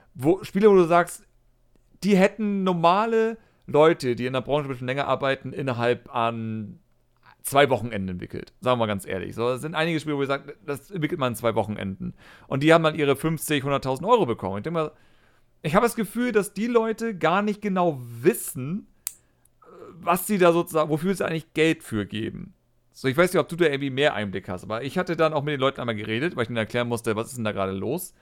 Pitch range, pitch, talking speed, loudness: 120-175 Hz, 145 Hz, 225 wpm, -24 LUFS